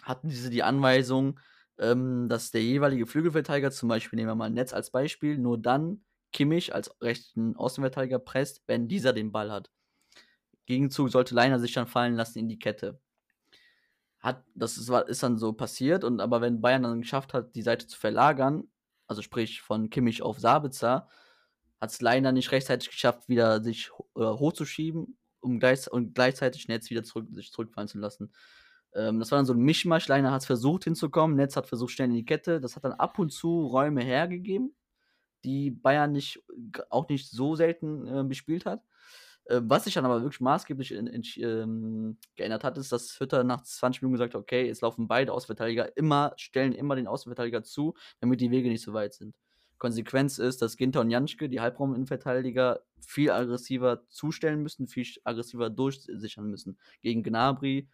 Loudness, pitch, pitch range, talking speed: -29 LUFS, 130 Hz, 120-145 Hz, 180 wpm